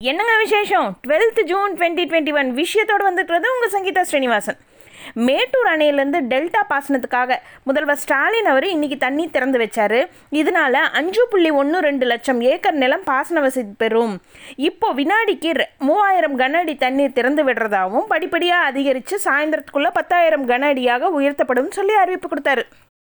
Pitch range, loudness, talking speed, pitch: 265-365 Hz, -17 LUFS, 135 wpm, 300 Hz